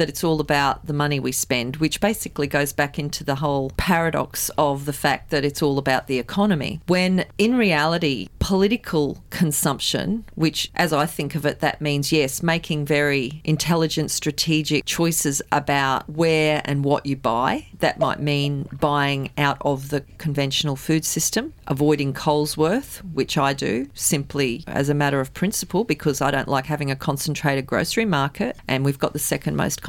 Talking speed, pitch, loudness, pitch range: 175 wpm, 150 Hz, -22 LUFS, 140-160 Hz